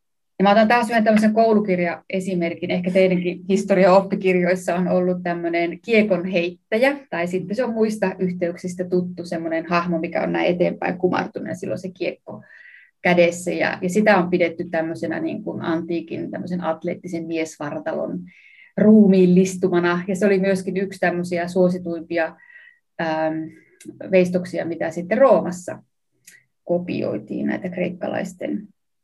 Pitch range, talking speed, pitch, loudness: 170-195 Hz, 120 wpm, 180 Hz, -20 LUFS